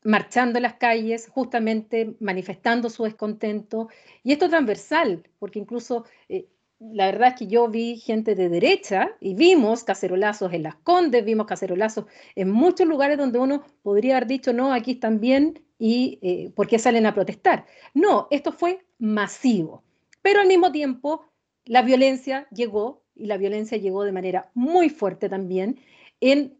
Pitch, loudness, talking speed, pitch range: 235 Hz, -22 LUFS, 160 wpm, 205-270 Hz